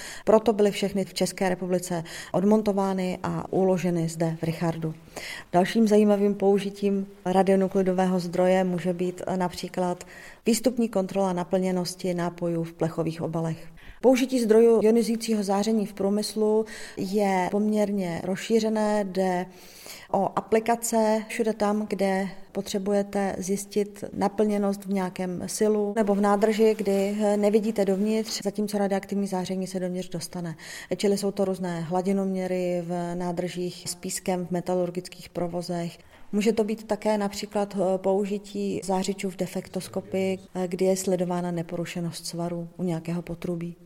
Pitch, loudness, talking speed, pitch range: 190 Hz, -26 LUFS, 120 wpm, 180-205 Hz